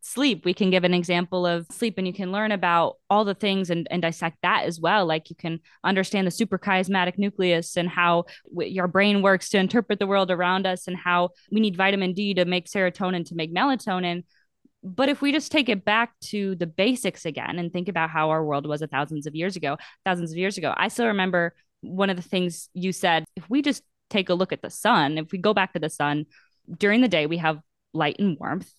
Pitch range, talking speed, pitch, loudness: 170-200 Hz, 235 wpm, 185 Hz, -24 LUFS